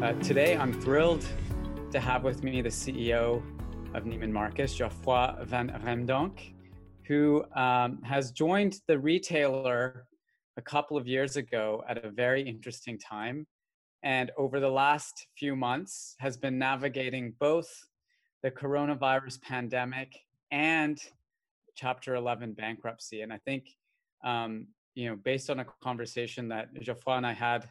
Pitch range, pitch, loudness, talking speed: 120-140 Hz, 130 Hz, -31 LUFS, 140 wpm